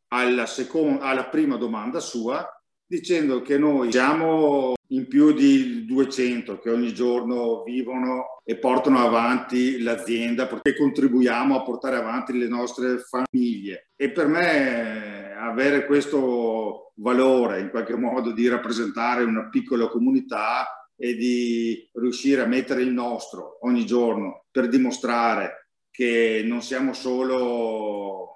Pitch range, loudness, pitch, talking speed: 120-135 Hz, -23 LUFS, 125 Hz, 125 wpm